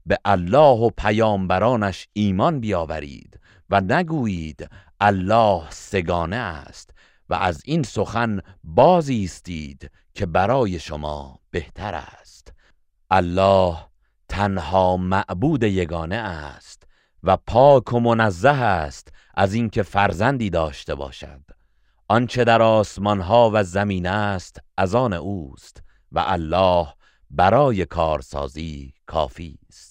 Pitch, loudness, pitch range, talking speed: 95 Hz, -20 LUFS, 85-110 Hz, 105 wpm